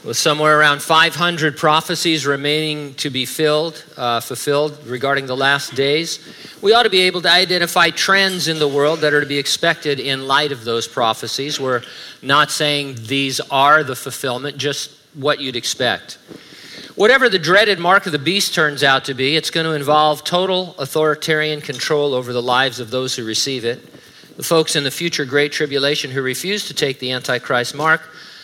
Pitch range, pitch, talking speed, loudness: 135-160 Hz, 145 Hz, 185 wpm, -16 LUFS